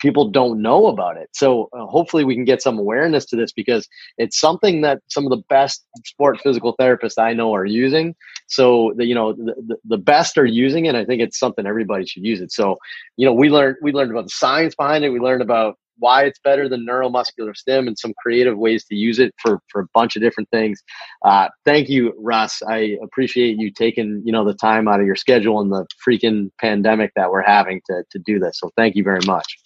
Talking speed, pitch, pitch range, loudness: 235 wpm, 115 Hz, 110-130 Hz, -17 LUFS